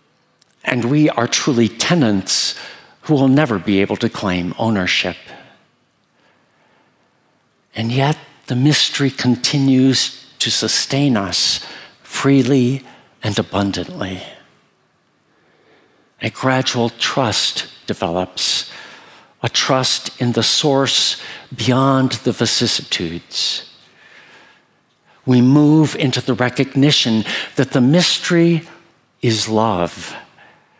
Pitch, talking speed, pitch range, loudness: 125 Hz, 90 wpm, 110-135 Hz, -16 LUFS